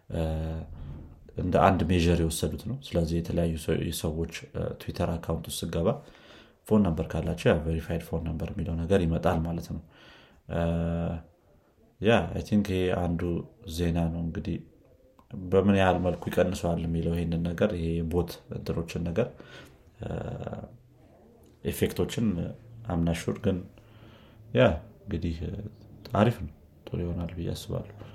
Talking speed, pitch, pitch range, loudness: 110 wpm, 85 Hz, 80-95 Hz, -29 LUFS